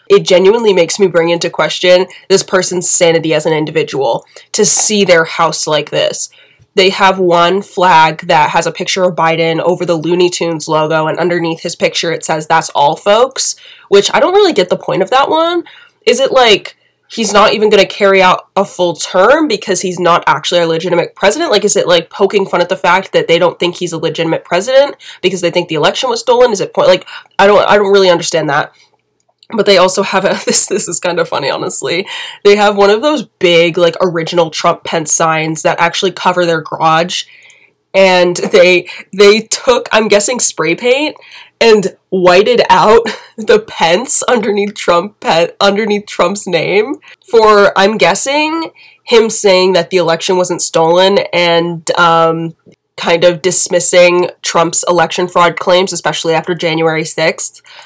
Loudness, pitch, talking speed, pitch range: -10 LUFS, 185 Hz, 185 wpm, 170-205 Hz